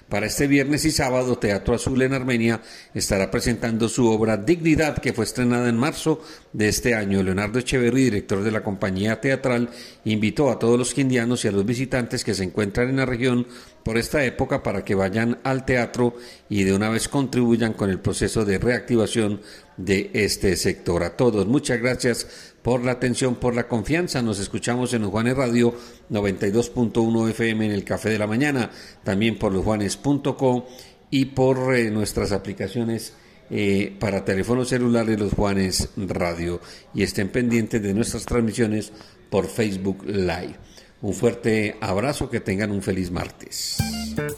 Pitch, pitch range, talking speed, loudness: 115 Hz, 105-125 Hz, 160 wpm, -22 LUFS